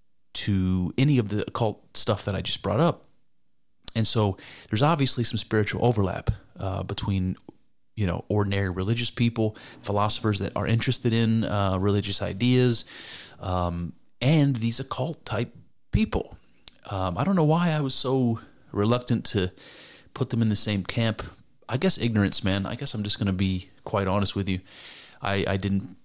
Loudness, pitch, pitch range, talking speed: -26 LUFS, 105 Hz, 100-120 Hz, 170 wpm